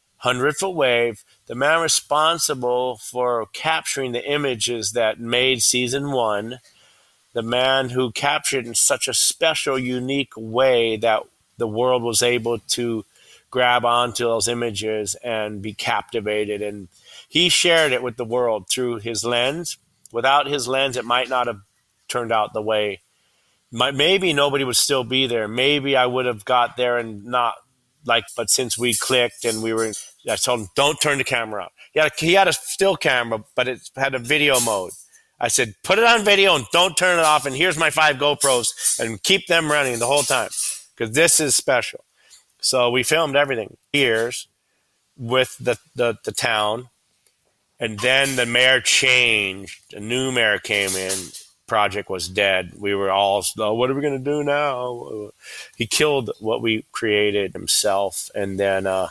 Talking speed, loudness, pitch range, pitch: 175 wpm, -19 LUFS, 110-140 Hz, 125 Hz